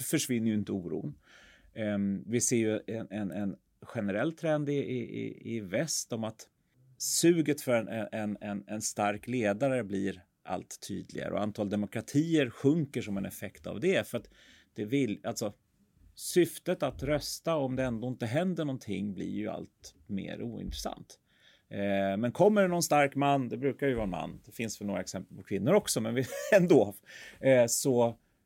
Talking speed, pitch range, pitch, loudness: 170 wpm, 100-140 Hz, 115 Hz, -31 LUFS